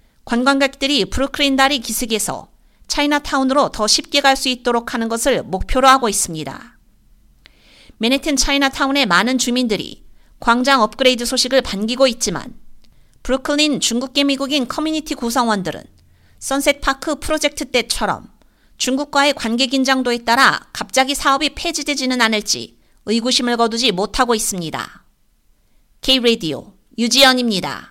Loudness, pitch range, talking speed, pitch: -16 LUFS, 230-275 Hz, 335 characters per minute, 260 Hz